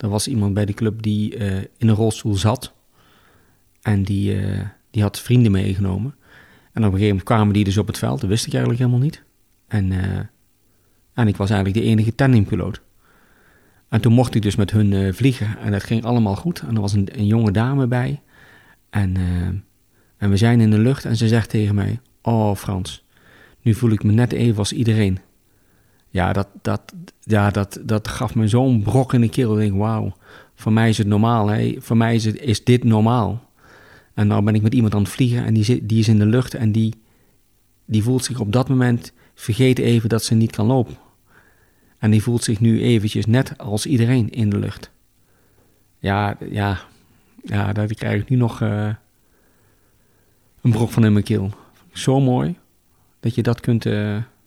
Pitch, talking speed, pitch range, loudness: 110 Hz, 205 wpm, 100-120 Hz, -19 LUFS